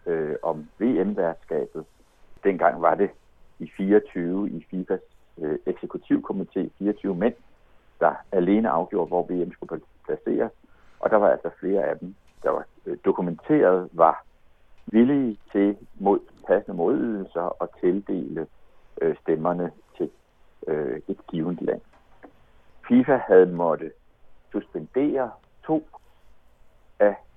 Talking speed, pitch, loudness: 120 wpm, 155 Hz, -25 LUFS